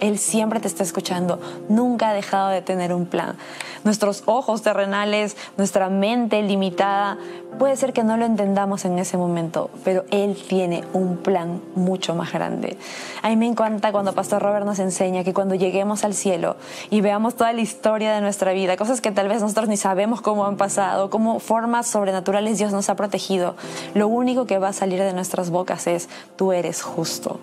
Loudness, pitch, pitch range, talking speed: -21 LUFS, 200 Hz, 185-215 Hz, 190 wpm